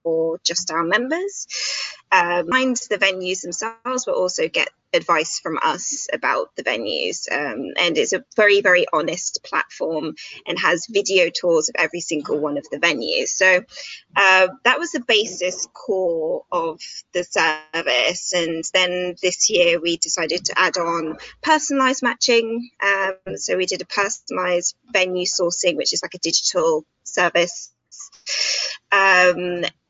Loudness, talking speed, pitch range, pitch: -19 LUFS, 145 wpm, 175-270 Hz, 190 Hz